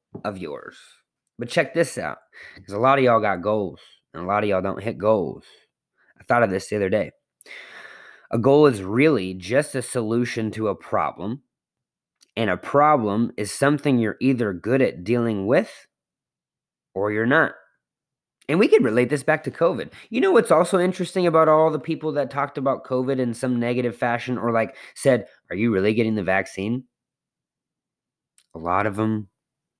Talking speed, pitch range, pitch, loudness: 180 wpm, 110-145 Hz, 125 Hz, -22 LUFS